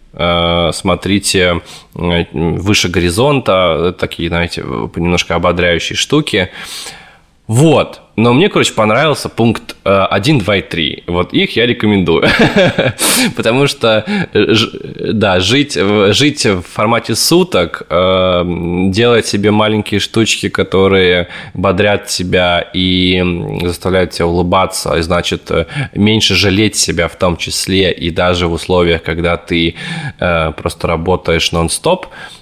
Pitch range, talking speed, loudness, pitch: 85-105 Hz, 105 wpm, -12 LUFS, 90 Hz